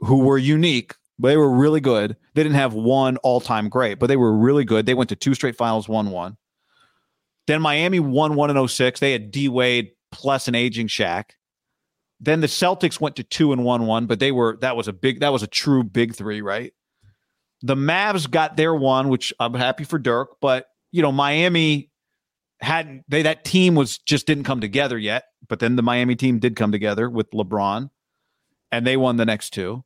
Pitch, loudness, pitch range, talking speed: 130 Hz, -20 LUFS, 115-145 Hz, 210 wpm